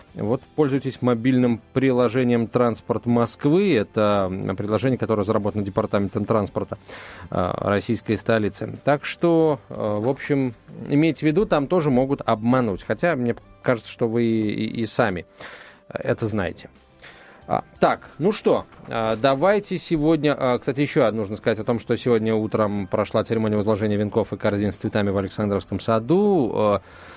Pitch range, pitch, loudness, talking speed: 105-130 Hz, 115 Hz, -22 LUFS, 150 wpm